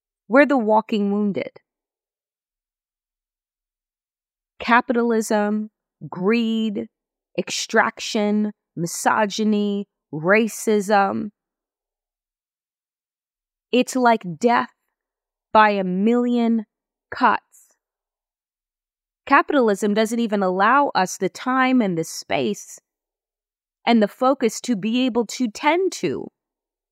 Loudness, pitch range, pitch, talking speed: -20 LUFS, 205-245 Hz, 220 Hz, 80 wpm